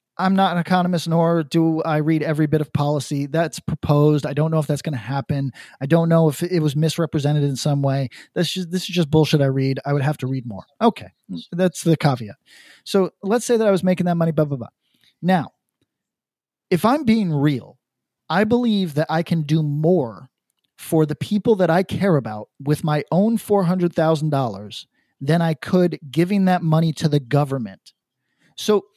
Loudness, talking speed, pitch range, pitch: -20 LUFS, 205 wpm, 145-180 Hz, 160 Hz